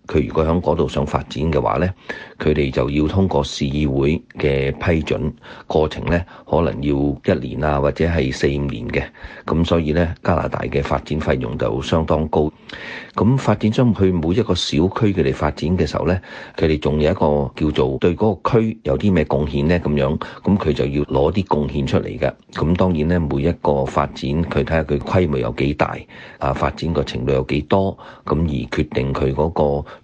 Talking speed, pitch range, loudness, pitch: 285 characters per minute, 70-90 Hz, -19 LUFS, 75 Hz